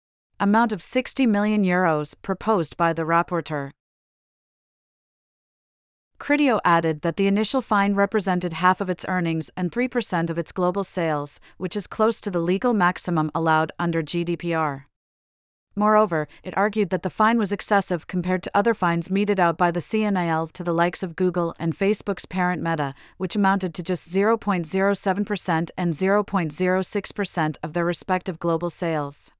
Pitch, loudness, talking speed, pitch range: 180 Hz, -22 LUFS, 150 wpm, 165-200 Hz